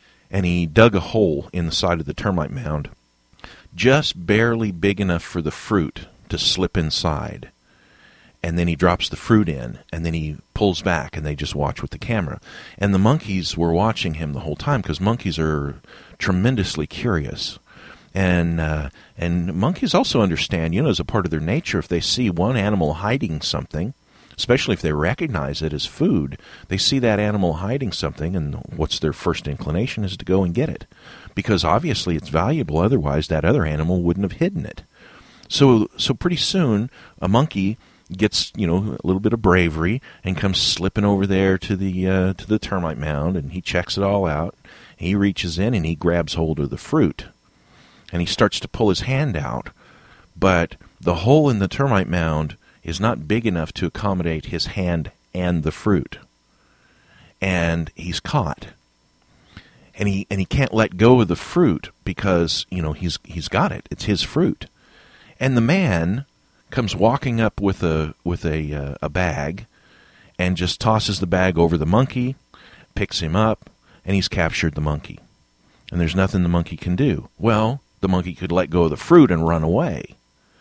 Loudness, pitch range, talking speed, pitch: -21 LUFS, 80-100 Hz, 185 wpm, 90 Hz